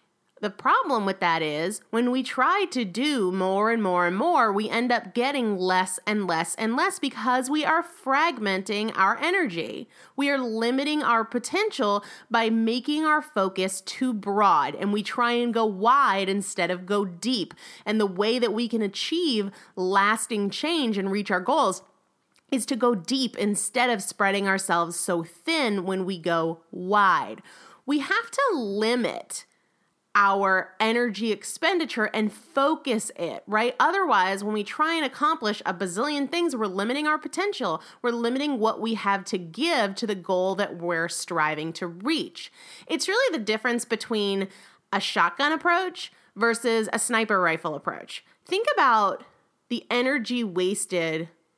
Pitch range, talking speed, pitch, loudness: 195-265 Hz, 155 wpm, 225 Hz, -25 LUFS